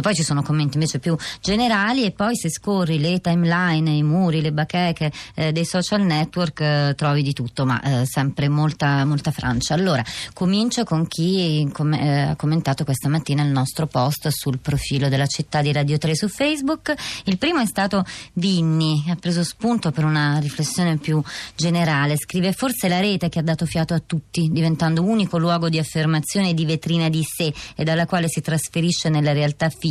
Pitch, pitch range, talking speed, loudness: 160 Hz, 150-175 Hz, 185 wpm, -21 LUFS